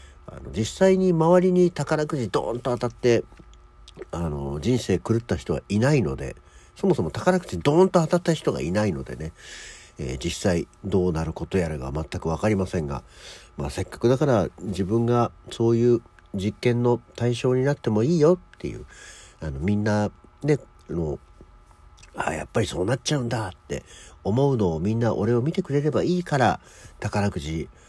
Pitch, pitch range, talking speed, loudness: 110 Hz, 90-130 Hz, 335 characters per minute, -24 LUFS